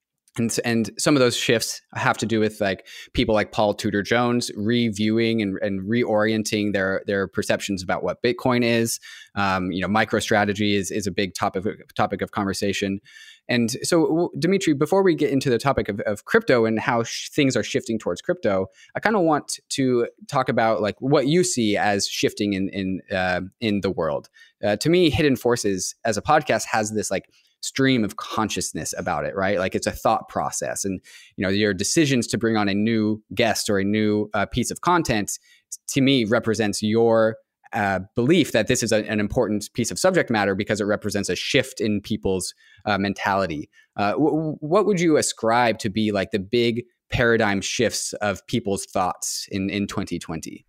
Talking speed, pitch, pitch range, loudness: 190 wpm, 110 Hz, 100-120 Hz, -22 LUFS